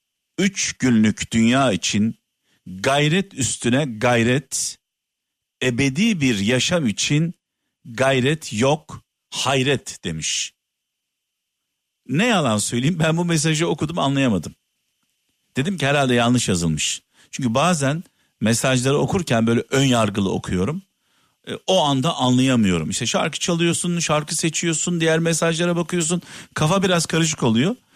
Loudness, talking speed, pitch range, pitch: -20 LUFS, 110 wpm, 120-170 Hz, 140 Hz